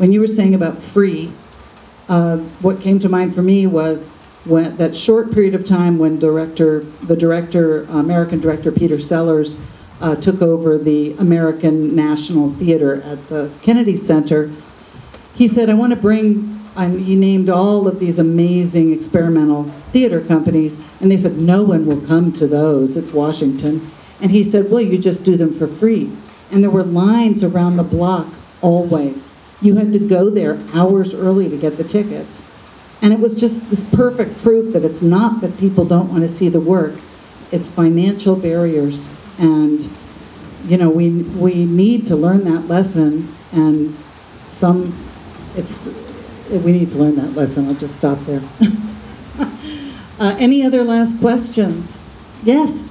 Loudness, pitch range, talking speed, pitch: -15 LUFS, 155-200 Hz, 165 wpm, 175 Hz